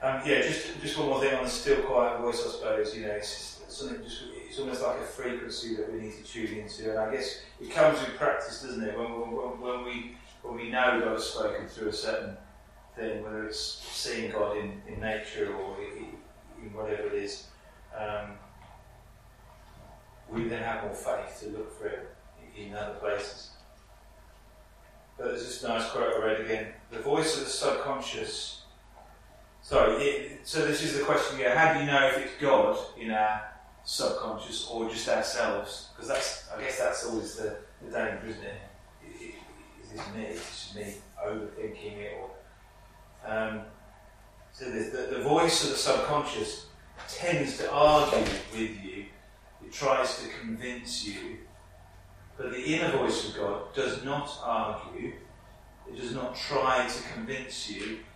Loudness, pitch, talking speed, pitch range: -31 LUFS, 110 Hz, 175 wpm, 105-135 Hz